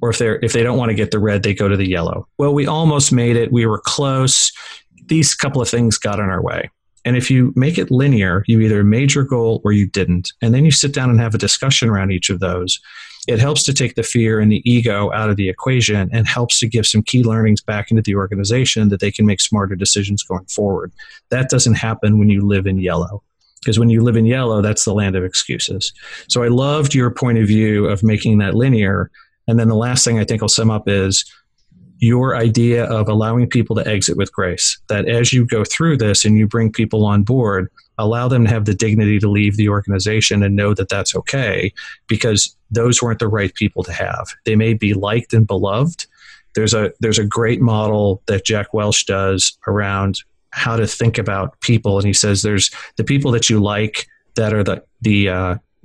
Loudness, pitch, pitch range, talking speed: -15 LUFS, 110 Hz, 100-120 Hz, 230 wpm